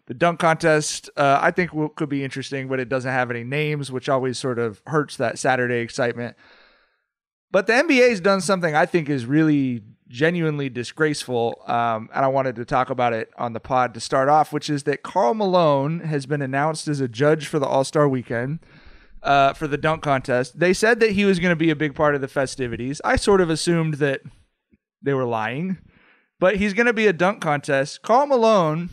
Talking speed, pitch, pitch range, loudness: 215 wpm, 145 Hz, 130-165 Hz, -21 LUFS